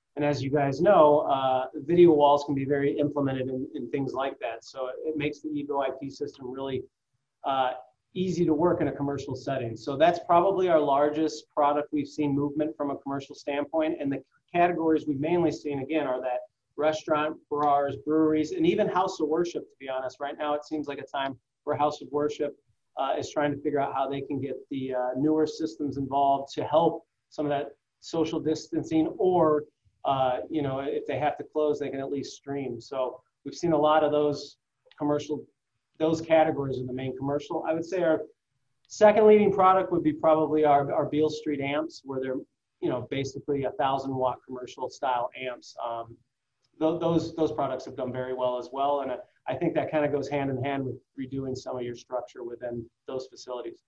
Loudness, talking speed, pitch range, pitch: -27 LUFS, 205 wpm, 135-155 Hz, 145 Hz